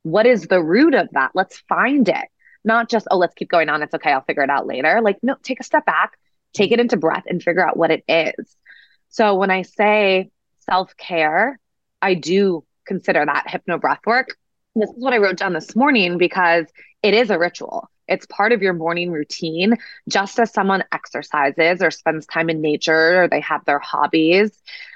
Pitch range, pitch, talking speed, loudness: 165-215 Hz, 185 Hz, 205 wpm, -18 LUFS